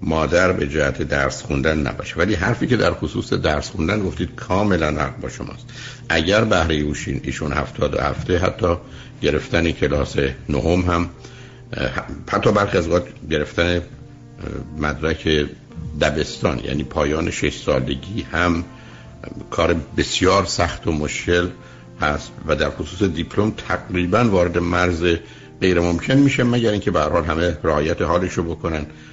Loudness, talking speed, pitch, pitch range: -20 LUFS, 135 wpm, 85 Hz, 75-95 Hz